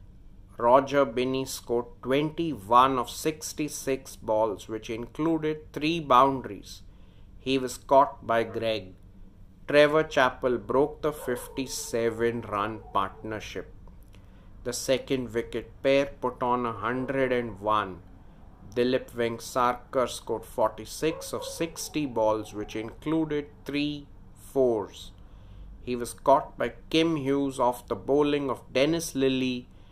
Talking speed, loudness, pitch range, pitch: 105 wpm, -27 LUFS, 100-135 Hz, 120 Hz